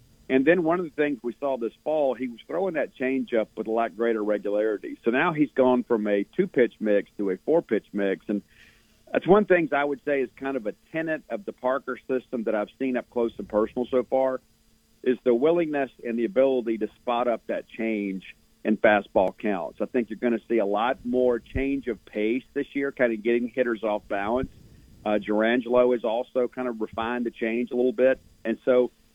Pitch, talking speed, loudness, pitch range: 125 Hz, 220 wpm, -26 LUFS, 110-130 Hz